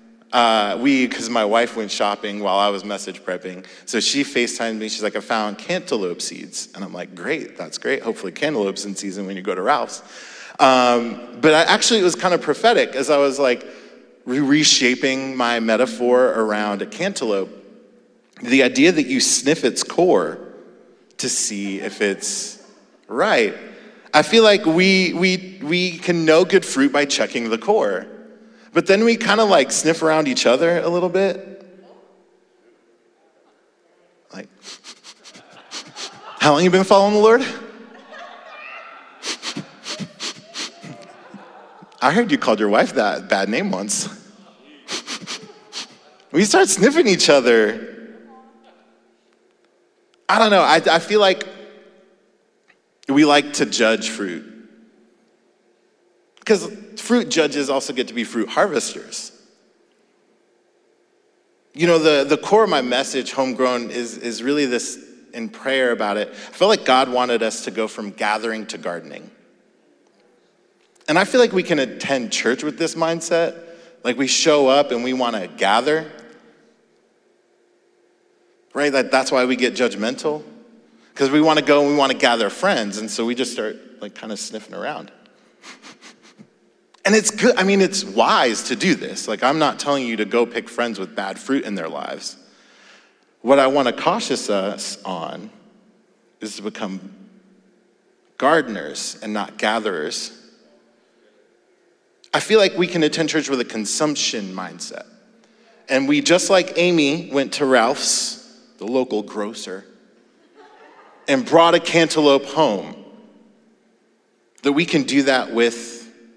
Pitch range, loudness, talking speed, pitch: 120-195 Hz, -18 LUFS, 150 wpm, 150 Hz